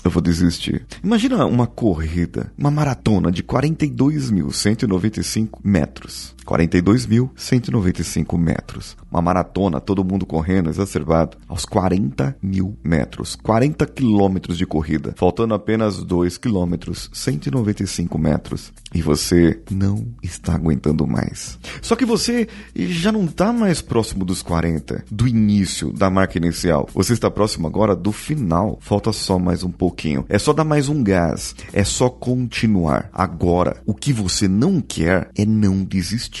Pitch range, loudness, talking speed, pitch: 85-120 Hz, -19 LUFS, 135 wpm, 100 Hz